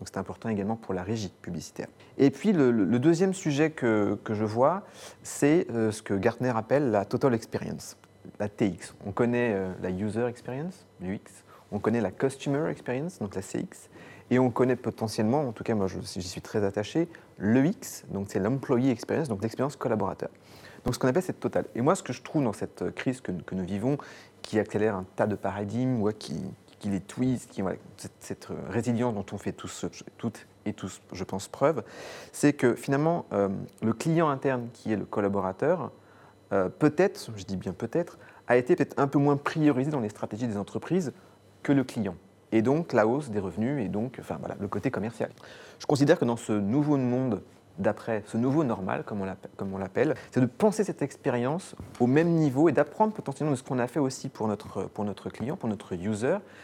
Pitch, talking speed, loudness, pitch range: 115 Hz, 205 wpm, -28 LUFS, 100-140 Hz